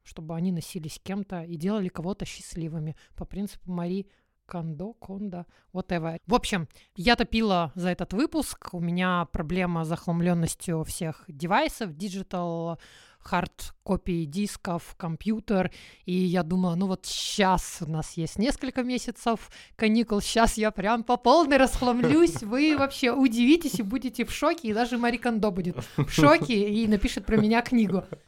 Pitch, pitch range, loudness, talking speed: 195 Hz, 175-235 Hz, -26 LUFS, 150 wpm